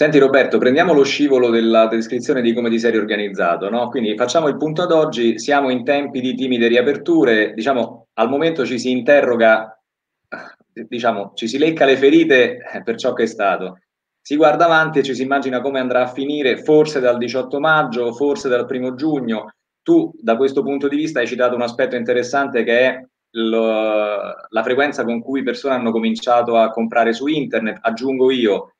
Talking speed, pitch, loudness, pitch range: 185 wpm, 125 Hz, -17 LUFS, 115-140 Hz